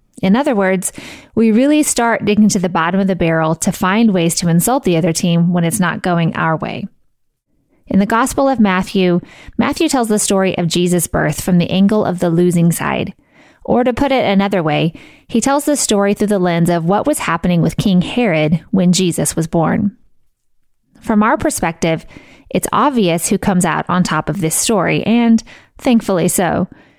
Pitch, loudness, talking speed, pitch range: 195 Hz, -14 LUFS, 190 wpm, 175-230 Hz